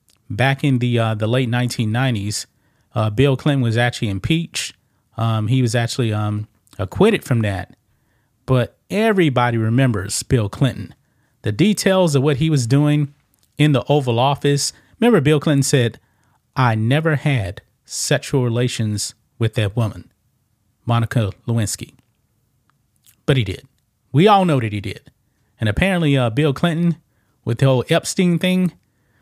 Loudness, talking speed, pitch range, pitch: -18 LUFS, 145 wpm, 115-145 Hz, 125 Hz